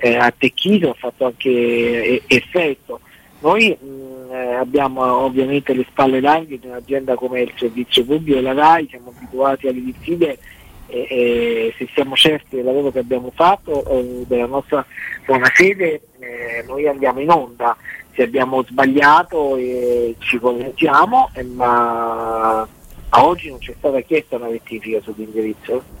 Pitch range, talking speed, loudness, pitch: 120-140 Hz, 145 wpm, -16 LUFS, 130 Hz